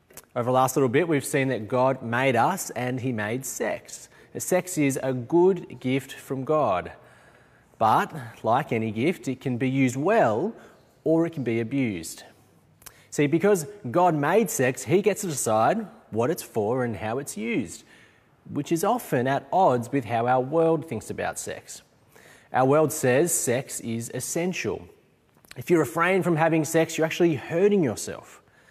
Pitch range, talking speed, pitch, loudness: 125-165 Hz, 170 wpm, 135 Hz, -25 LUFS